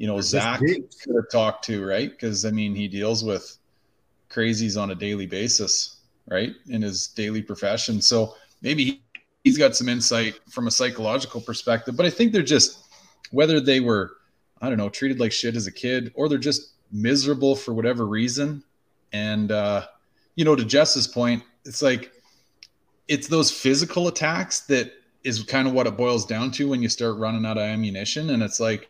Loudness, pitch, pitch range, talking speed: -23 LUFS, 115 Hz, 110-135 Hz, 190 wpm